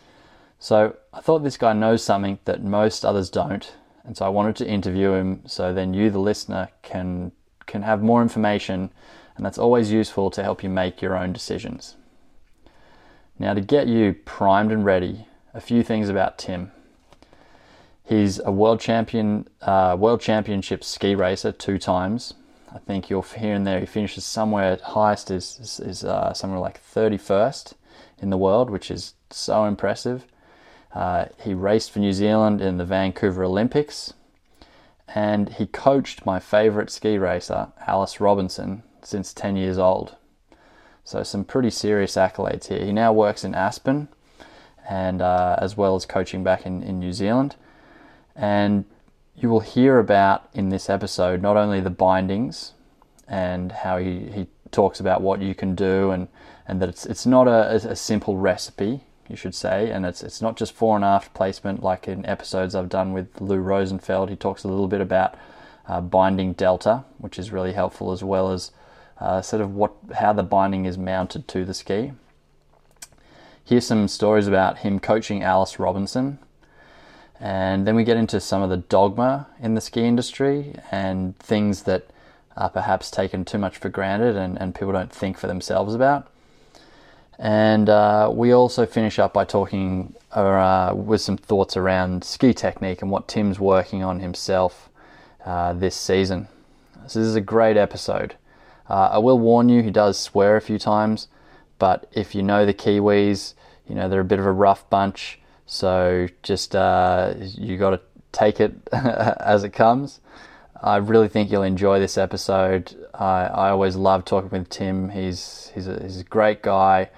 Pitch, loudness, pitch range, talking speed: 100 Hz, -21 LUFS, 95-110 Hz, 175 wpm